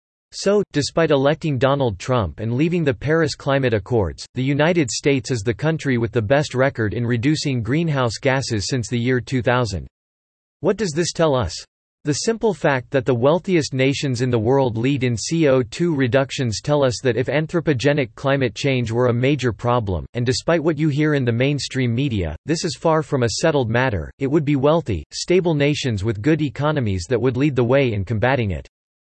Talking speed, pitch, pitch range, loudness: 190 wpm, 135 Hz, 120-150 Hz, -20 LUFS